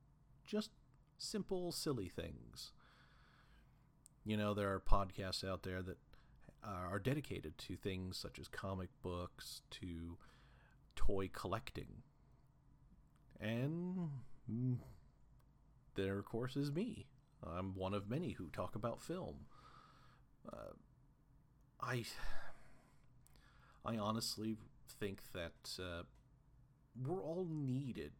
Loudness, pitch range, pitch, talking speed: -45 LUFS, 95-140 Hz, 125 Hz, 100 wpm